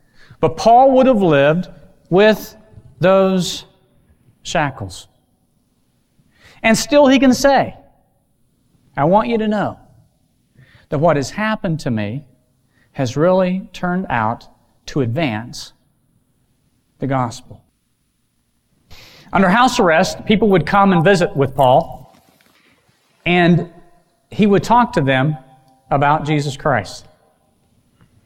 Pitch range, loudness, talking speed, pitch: 130-195 Hz, -15 LUFS, 110 wpm, 160 Hz